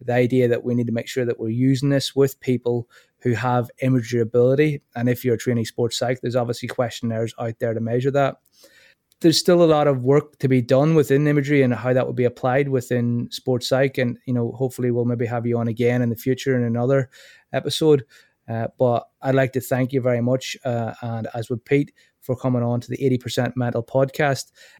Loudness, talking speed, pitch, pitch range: -21 LUFS, 220 wpm, 125 Hz, 120-135 Hz